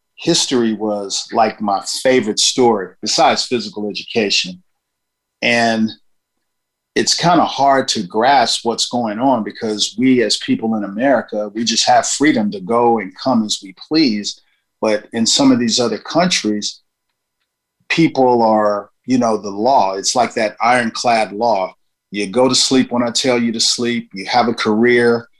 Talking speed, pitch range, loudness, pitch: 160 wpm, 105-130 Hz, -15 LUFS, 115 Hz